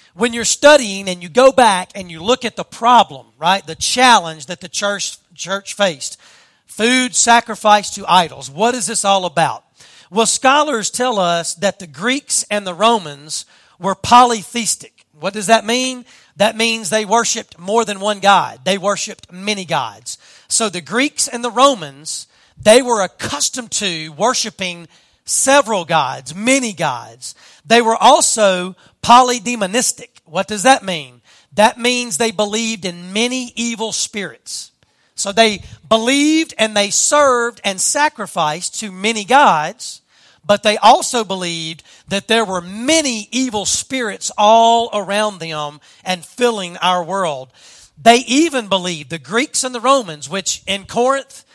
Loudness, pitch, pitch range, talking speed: -15 LUFS, 210 Hz, 180-240 Hz, 150 wpm